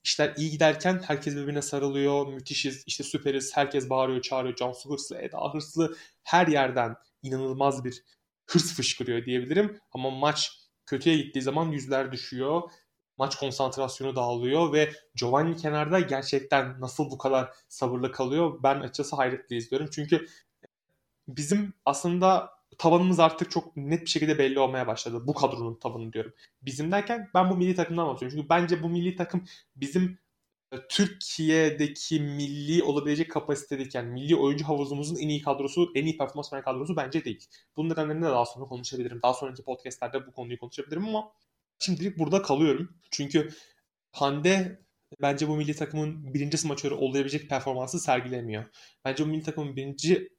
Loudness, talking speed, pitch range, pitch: -28 LUFS, 150 wpm, 135-160 Hz, 145 Hz